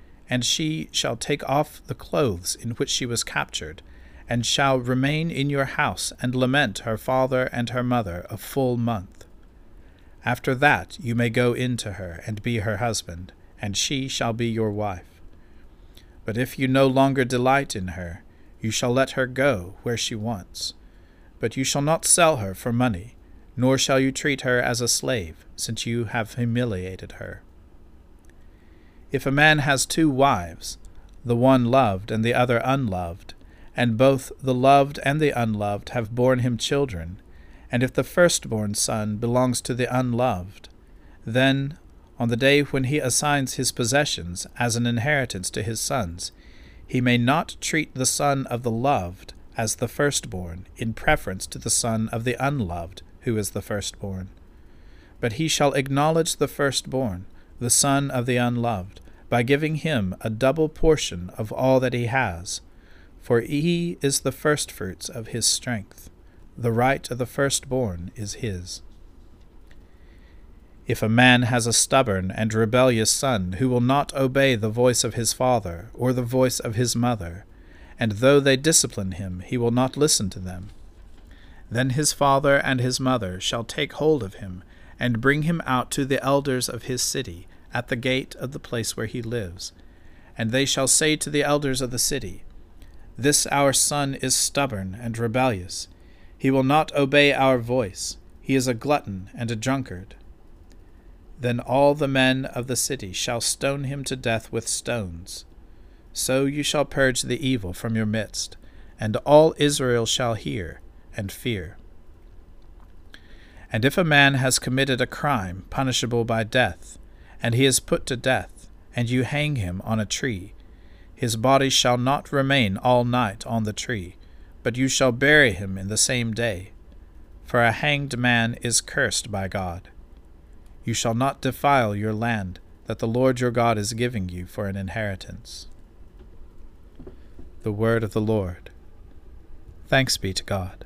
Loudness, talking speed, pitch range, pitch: -23 LUFS, 165 wpm, 90-130 Hz, 115 Hz